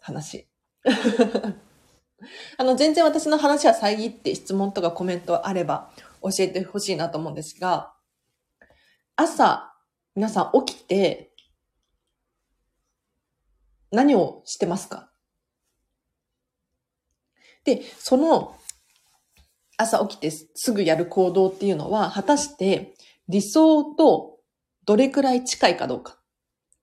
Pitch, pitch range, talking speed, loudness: 200 Hz, 175-260 Hz, 195 characters per minute, -22 LUFS